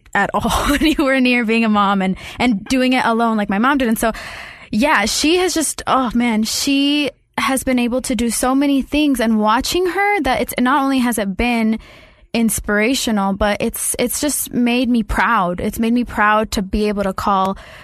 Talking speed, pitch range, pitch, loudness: 210 wpm, 220-265 Hz, 240 Hz, -16 LUFS